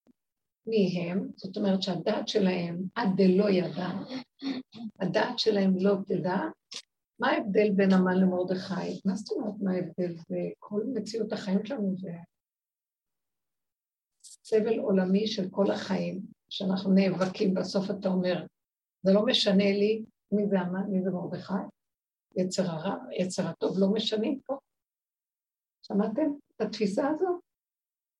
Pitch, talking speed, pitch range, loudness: 195 Hz, 130 wpm, 185-220 Hz, -29 LUFS